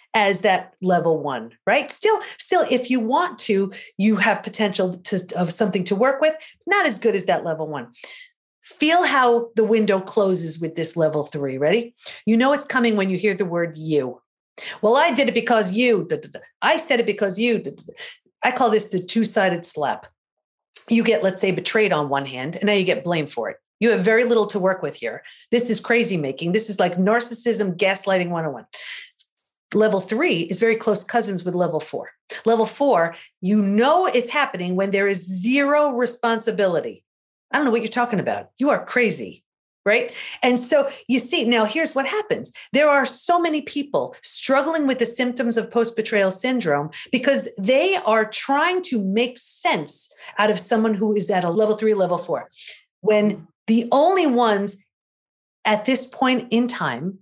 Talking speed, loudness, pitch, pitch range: 190 wpm, -21 LUFS, 220 Hz, 190-255 Hz